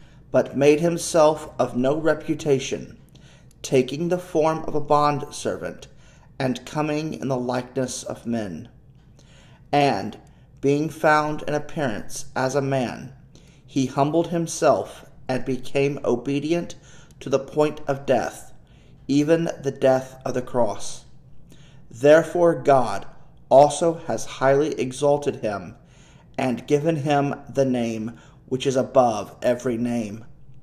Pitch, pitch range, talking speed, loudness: 140 Hz, 130-150 Hz, 120 wpm, -22 LUFS